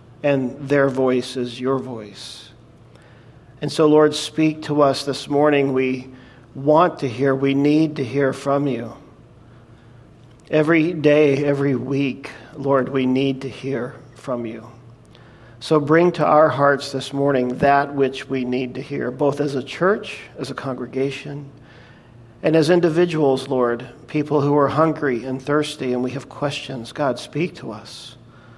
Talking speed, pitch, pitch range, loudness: 155 wpm, 135 Hz, 125-145 Hz, -20 LUFS